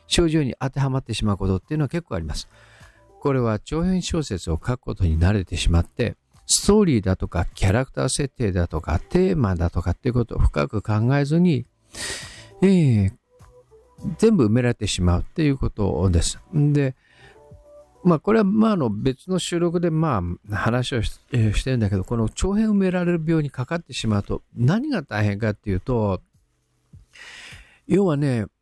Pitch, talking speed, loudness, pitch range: 120 Hz, 345 characters per minute, -22 LUFS, 95-160 Hz